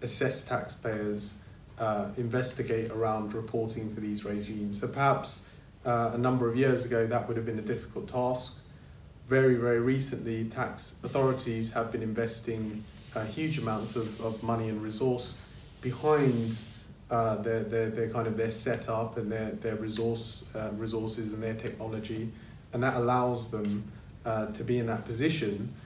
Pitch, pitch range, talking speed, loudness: 115 Hz, 110-125 Hz, 160 wpm, -31 LUFS